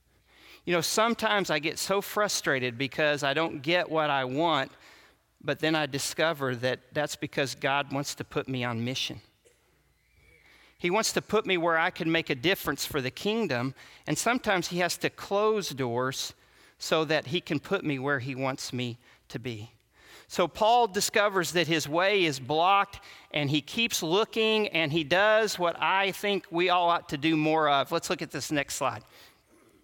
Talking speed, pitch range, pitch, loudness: 185 wpm, 140-185 Hz, 155 Hz, -27 LUFS